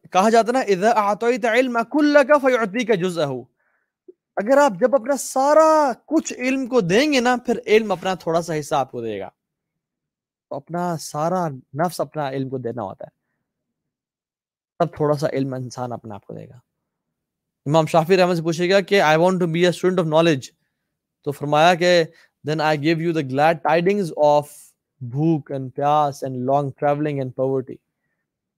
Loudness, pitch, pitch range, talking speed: -19 LUFS, 165 Hz, 145-225 Hz, 175 wpm